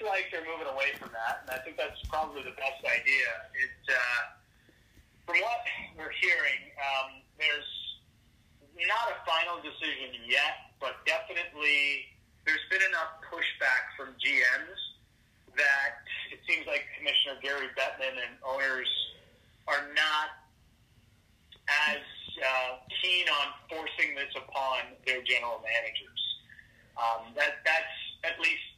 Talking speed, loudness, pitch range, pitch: 125 wpm, -30 LUFS, 120-150 Hz, 135 Hz